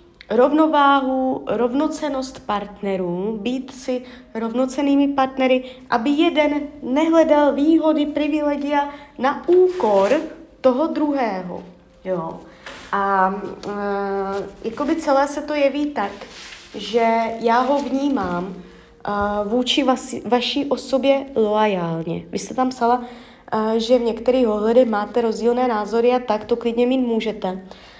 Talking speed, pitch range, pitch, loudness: 115 wpm, 215-285 Hz, 250 Hz, -20 LUFS